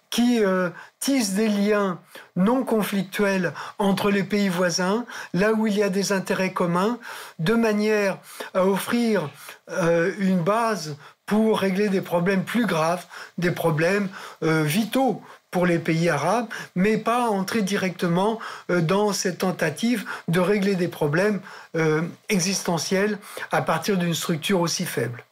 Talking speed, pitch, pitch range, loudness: 145 wpm, 195 Hz, 175-210 Hz, -23 LUFS